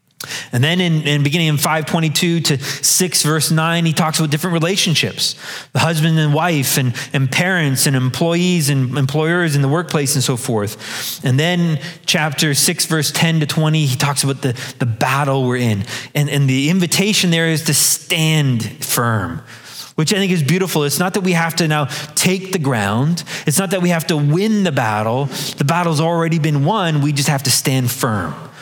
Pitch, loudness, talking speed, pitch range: 155 Hz, -16 LUFS, 195 wpm, 135-170 Hz